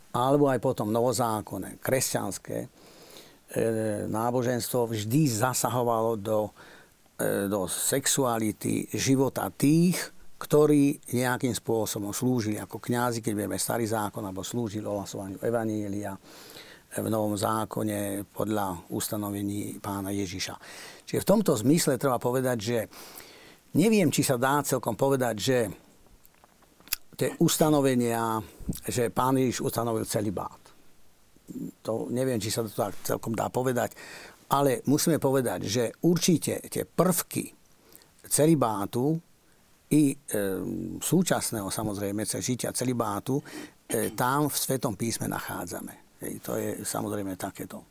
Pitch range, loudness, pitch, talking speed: 105-135 Hz, -28 LUFS, 120 Hz, 115 wpm